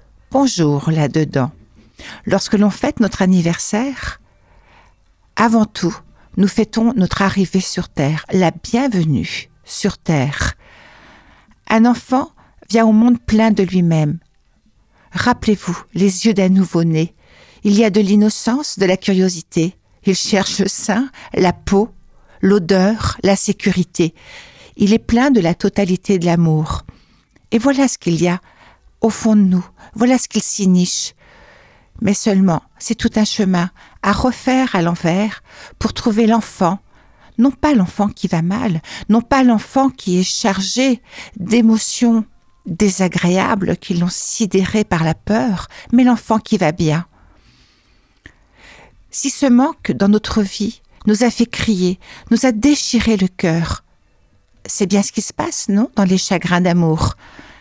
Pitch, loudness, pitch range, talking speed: 200 Hz, -16 LUFS, 180-225 Hz, 140 wpm